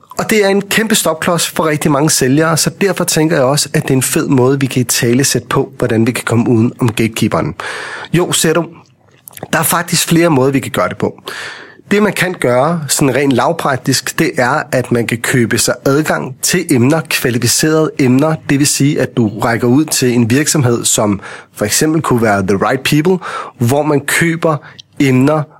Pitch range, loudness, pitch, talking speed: 125-160 Hz, -12 LUFS, 140 Hz, 205 wpm